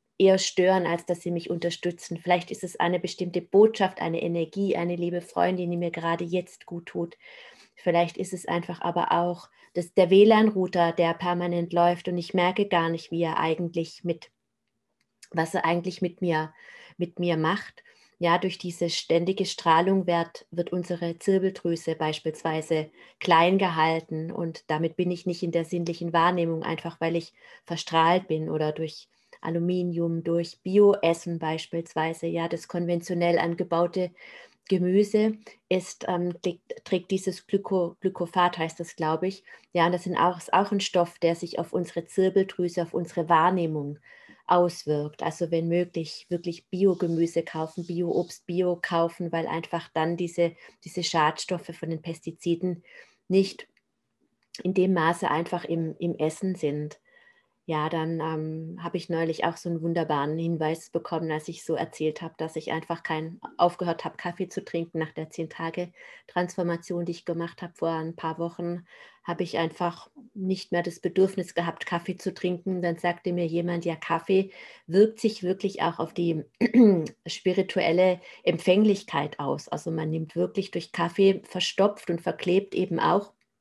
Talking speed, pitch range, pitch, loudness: 155 wpm, 165-185 Hz, 175 Hz, -27 LUFS